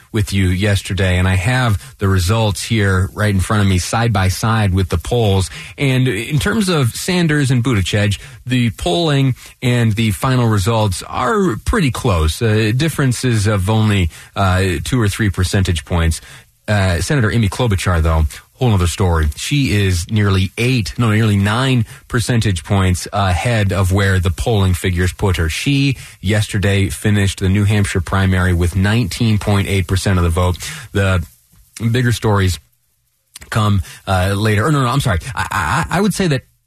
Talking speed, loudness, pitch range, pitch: 170 wpm, -16 LUFS, 95-120 Hz, 105 Hz